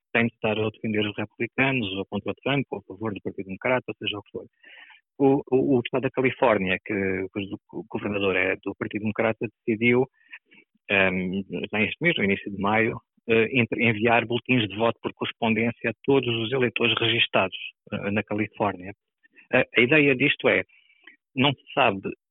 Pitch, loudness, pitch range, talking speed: 115 Hz, -24 LUFS, 105-125 Hz, 180 wpm